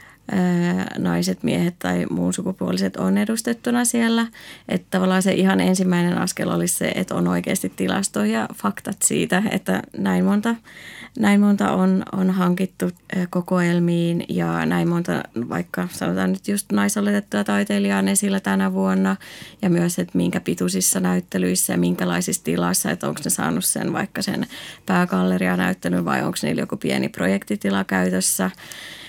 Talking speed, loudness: 145 wpm, -21 LUFS